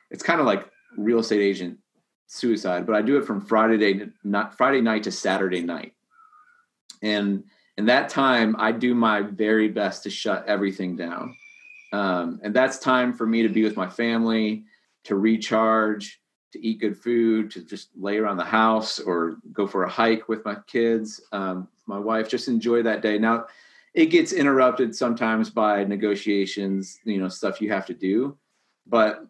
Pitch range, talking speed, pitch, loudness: 100-115 Hz, 180 wpm, 110 Hz, -23 LUFS